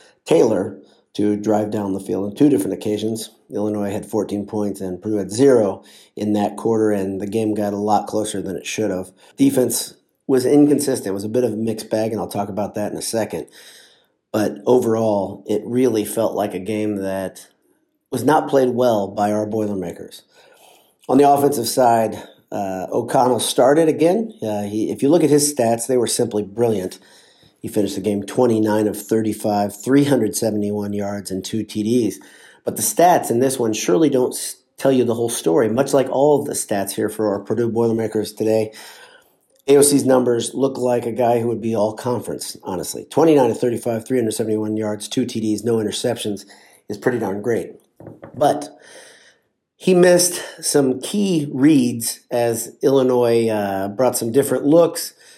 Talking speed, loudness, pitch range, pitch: 175 wpm, -19 LUFS, 105-125 Hz, 110 Hz